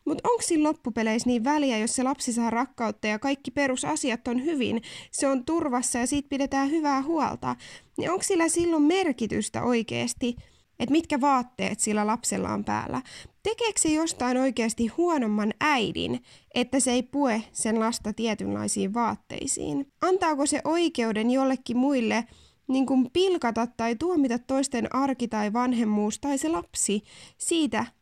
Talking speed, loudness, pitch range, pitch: 150 wpm, -26 LUFS, 230-295 Hz, 260 Hz